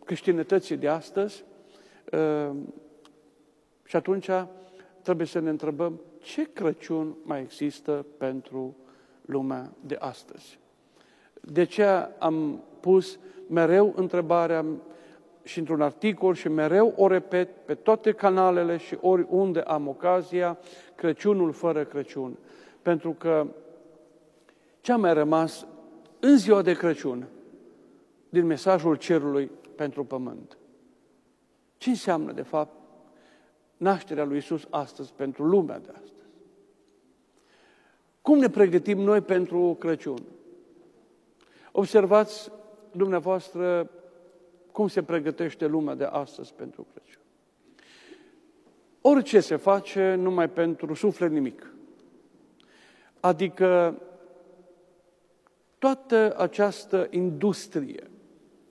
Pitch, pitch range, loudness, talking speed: 175 Hz, 160-205 Hz, -25 LUFS, 95 wpm